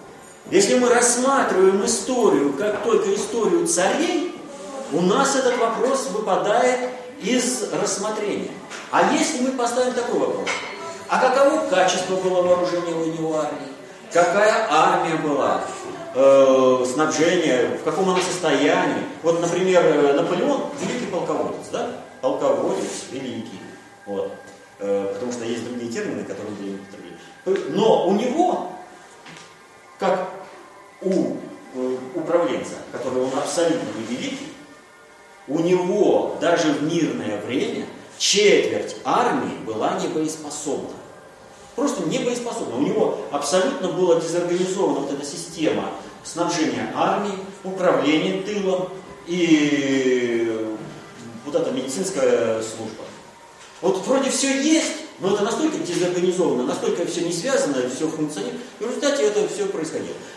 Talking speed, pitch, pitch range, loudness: 110 wpm, 190 Hz, 165-270 Hz, -21 LUFS